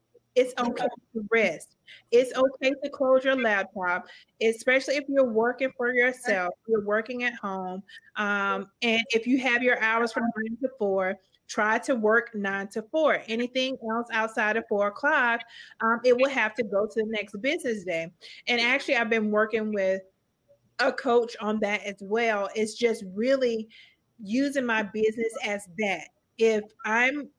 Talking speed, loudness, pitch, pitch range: 165 wpm, -26 LUFS, 225 Hz, 210-255 Hz